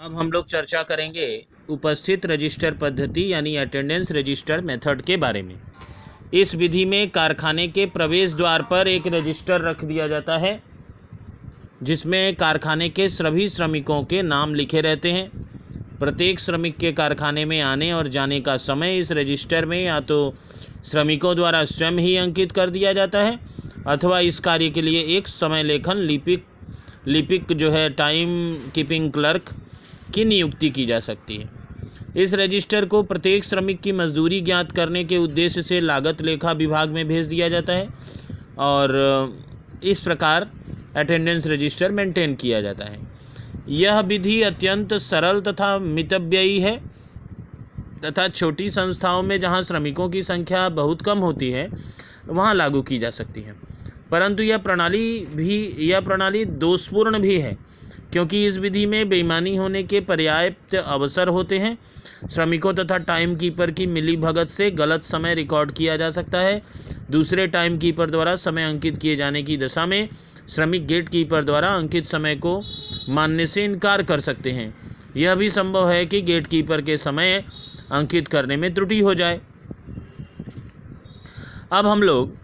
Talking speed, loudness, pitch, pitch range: 155 wpm, -21 LUFS, 165 Hz, 150-185 Hz